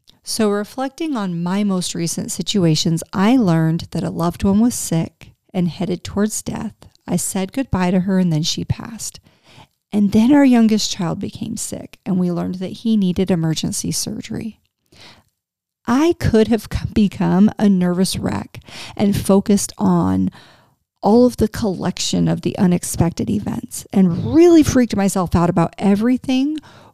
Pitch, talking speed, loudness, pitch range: 195 Hz, 150 wpm, -18 LUFS, 175-220 Hz